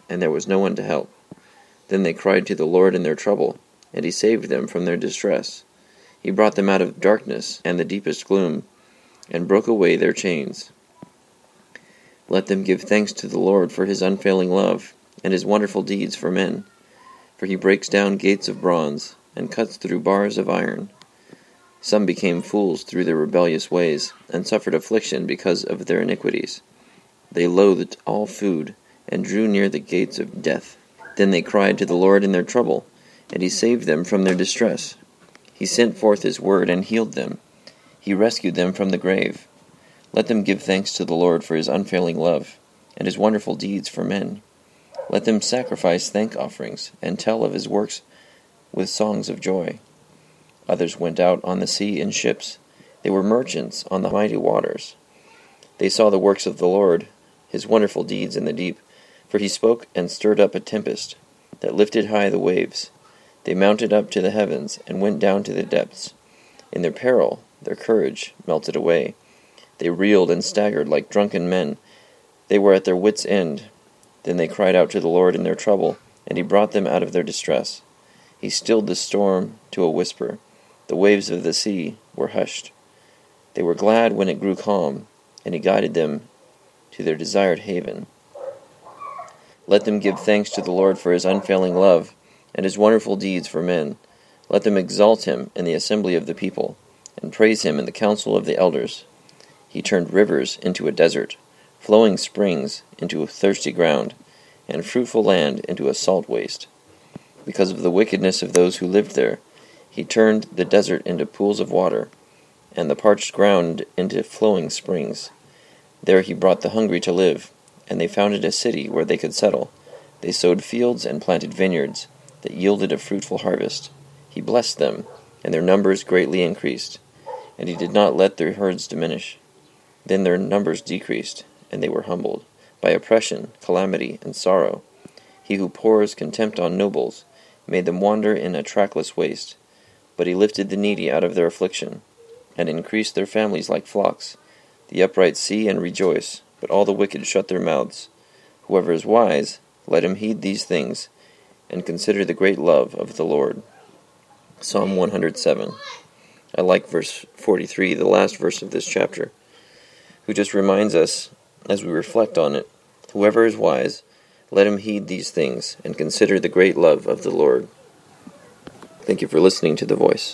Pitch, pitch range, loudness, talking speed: 100 Hz, 95-105 Hz, -20 LUFS, 180 wpm